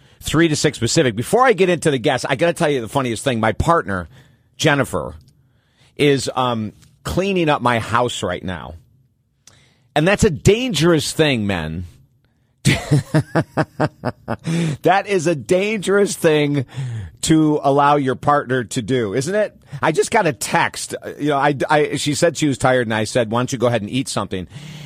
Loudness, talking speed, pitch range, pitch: -18 LUFS, 175 wpm, 120-160 Hz, 140 Hz